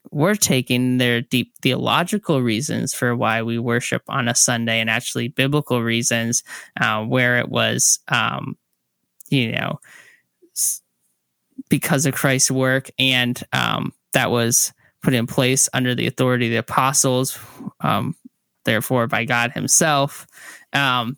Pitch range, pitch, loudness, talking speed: 115-135 Hz, 125 Hz, -19 LUFS, 135 wpm